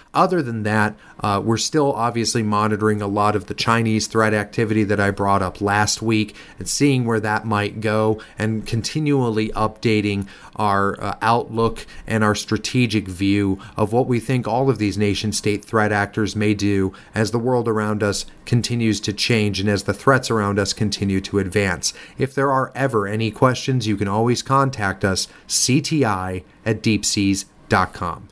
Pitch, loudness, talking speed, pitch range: 110 Hz, -20 LUFS, 170 wpm, 100-115 Hz